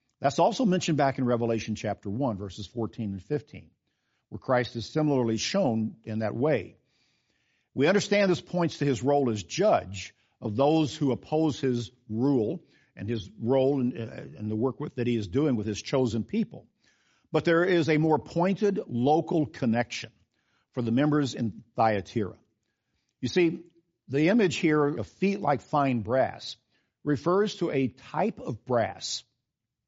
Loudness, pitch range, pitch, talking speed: -27 LUFS, 115-155 Hz, 130 Hz, 155 wpm